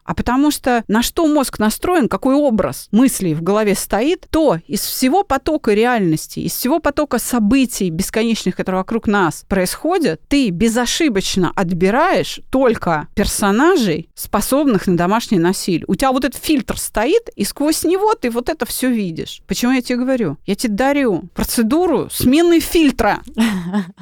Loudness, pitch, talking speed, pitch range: -16 LUFS, 235 Hz, 150 wpm, 195-280 Hz